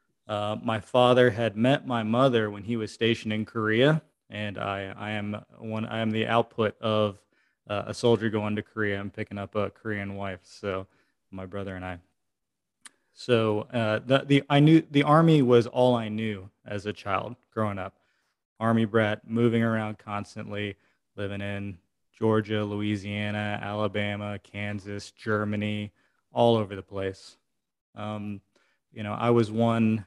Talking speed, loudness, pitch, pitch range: 160 wpm, -27 LUFS, 105 Hz, 100-115 Hz